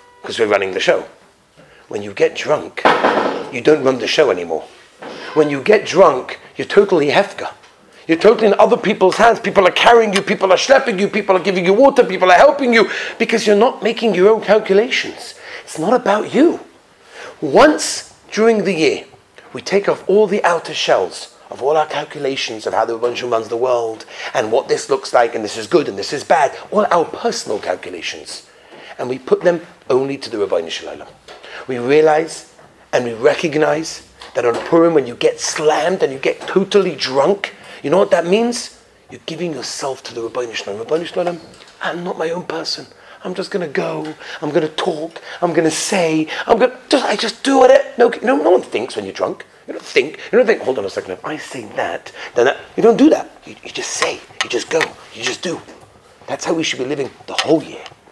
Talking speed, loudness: 215 wpm, -16 LUFS